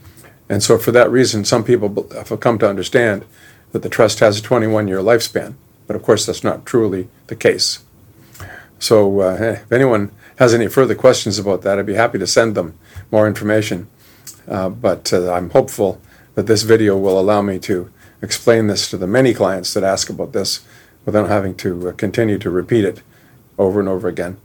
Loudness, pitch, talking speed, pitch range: -16 LUFS, 105 Hz, 190 wpm, 95-115 Hz